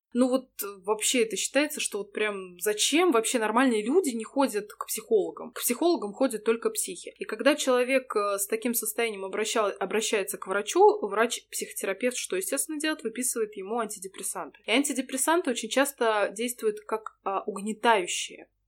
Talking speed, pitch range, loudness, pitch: 145 wpm, 210-270 Hz, -27 LUFS, 230 Hz